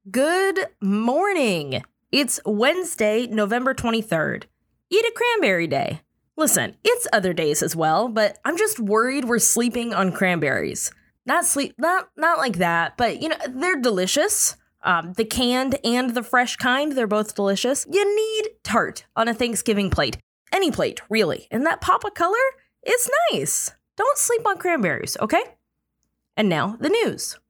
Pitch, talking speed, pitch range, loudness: 250 Hz, 155 wpm, 215-345 Hz, -21 LUFS